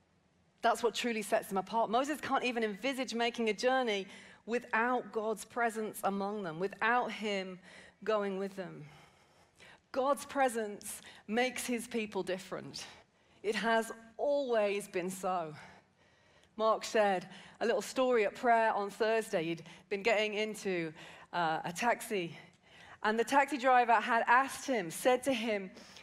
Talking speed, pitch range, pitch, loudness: 140 wpm, 195-235 Hz, 220 Hz, -33 LUFS